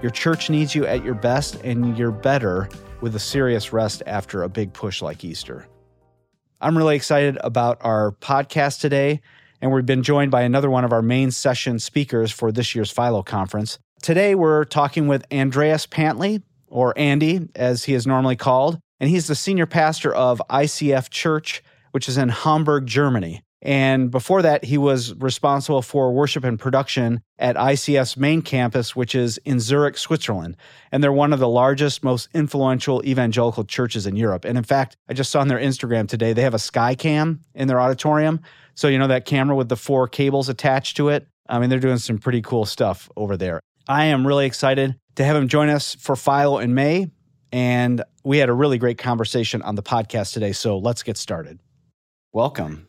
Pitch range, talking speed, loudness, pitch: 120-145 Hz, 190 wpm, -20 LUFS, 130 Hz